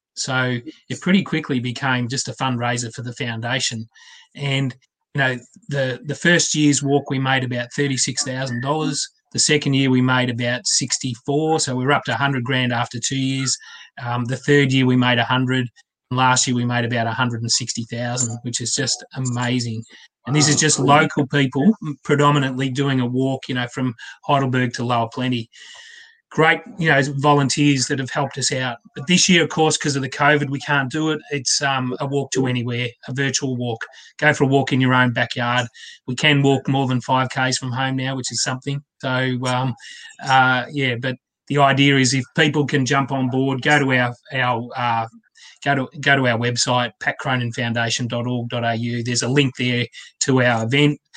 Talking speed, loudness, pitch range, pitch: 190 wpm, -19 LUFS, 125-140 Hz, 130 Hz